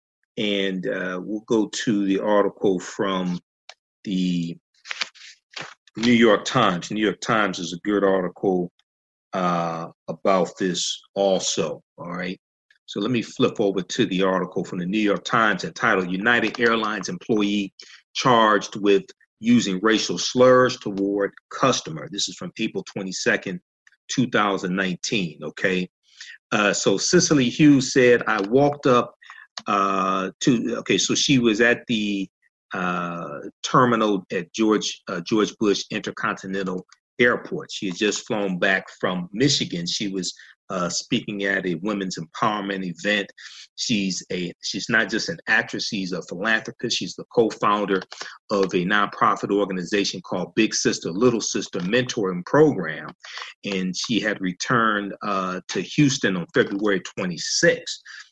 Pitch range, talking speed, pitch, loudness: 95-110 Hz, 135 wpm, 100 Hz, -22 LUFS